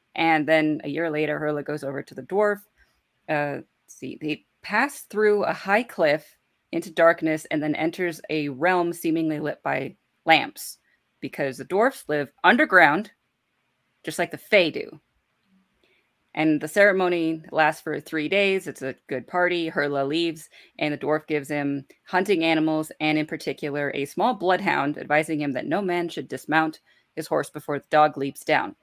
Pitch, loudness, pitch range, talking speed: 155 Hz, -24 LUFS, 150-175 Hz, 170 wpm